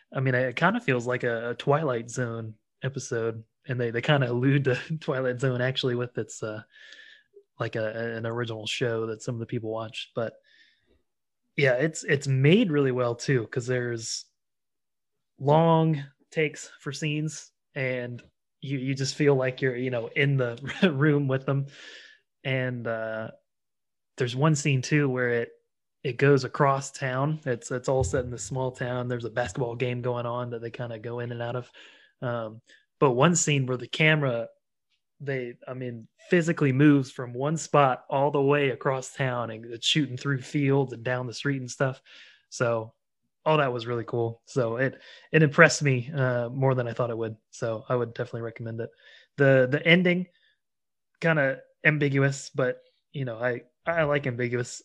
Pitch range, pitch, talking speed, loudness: 120-145 Hz, 130 Hz, 180 wpm, -26 LUFS